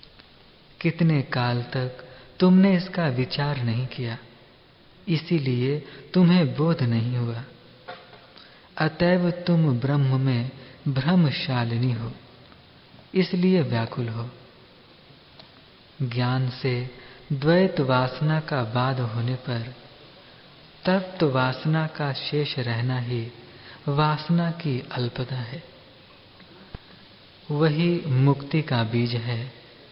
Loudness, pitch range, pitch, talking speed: -24 LUFS, 125-160 Hz, 130 Hz, 90 wpm